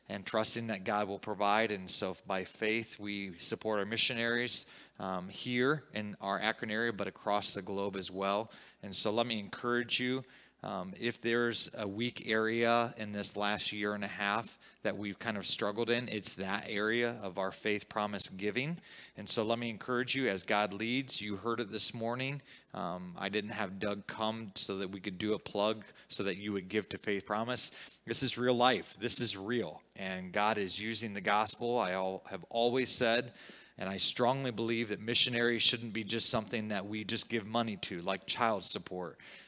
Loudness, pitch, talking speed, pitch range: -32 LUFS, 110 Hz, 200 wpm, 100-120 Hz